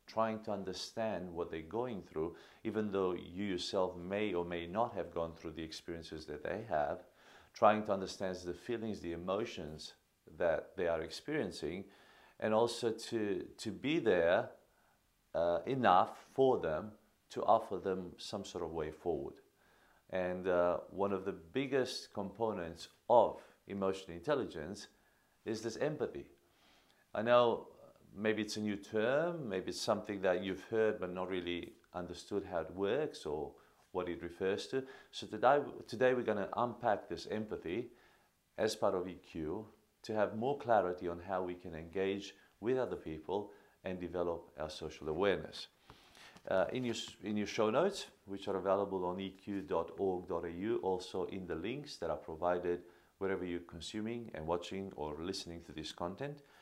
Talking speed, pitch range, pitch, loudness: 160 wpm, 85-105 Hz, 95 Hz, -38 LUFS